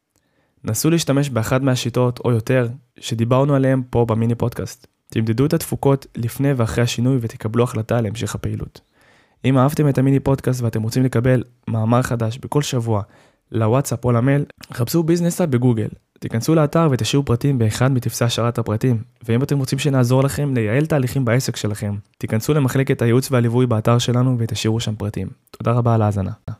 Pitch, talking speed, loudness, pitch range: 120 Hz, 150 wpm, -19 LUFS, 115-135 Hz